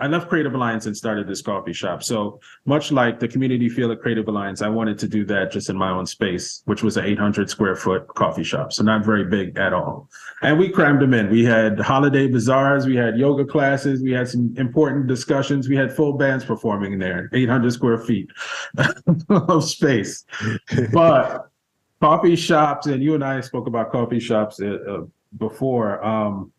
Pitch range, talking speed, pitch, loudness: 110-140 Hz, 190 wpm, 125 Hz, -20 LUFS